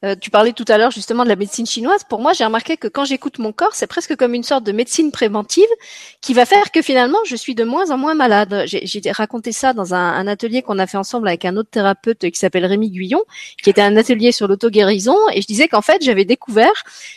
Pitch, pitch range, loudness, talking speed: 230 Hz, 205-275 Hz, -15 LUFS, 255 wpm